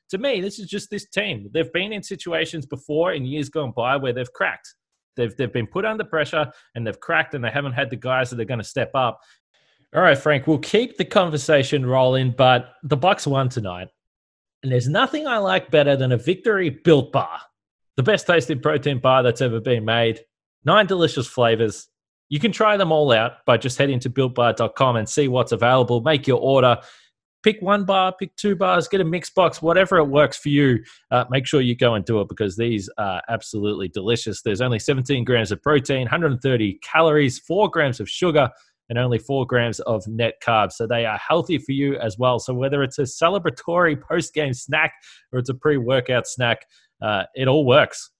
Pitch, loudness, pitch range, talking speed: 135 Hz, -20 LUFS, 120-160 Hz, 205 wpm